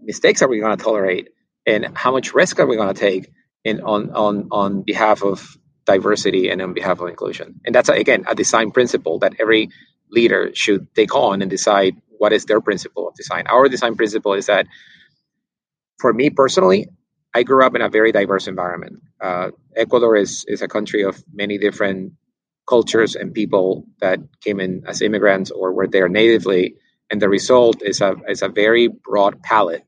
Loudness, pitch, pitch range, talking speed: -17 LUFS, 105 Hz, 100-120 Hz, 190 wpm